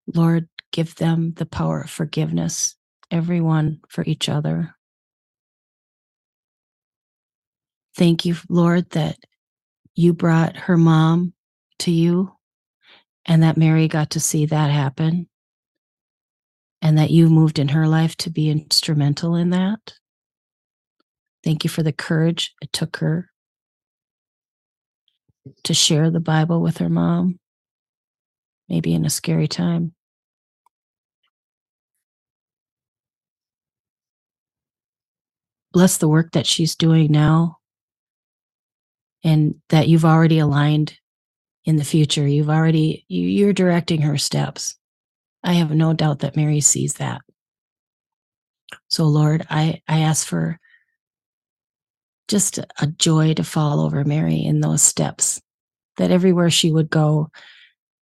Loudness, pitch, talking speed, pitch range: -18 LUFS, 160 Hz, 115 wpm, 150-170 Hz